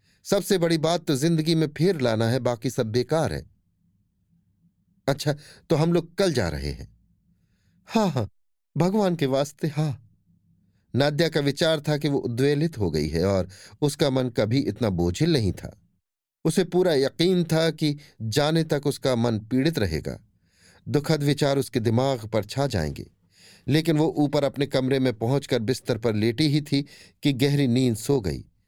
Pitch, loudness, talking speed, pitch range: 135 Hz, -24 LUFS, 170 wpm, 110-155 Hz